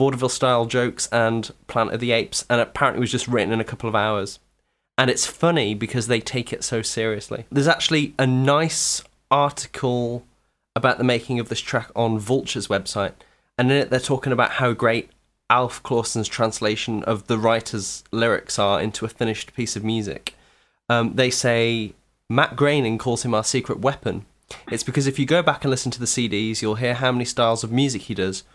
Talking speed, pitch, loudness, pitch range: 200 wpm, 120 Hz, -22 LUFS, 115-130 Hz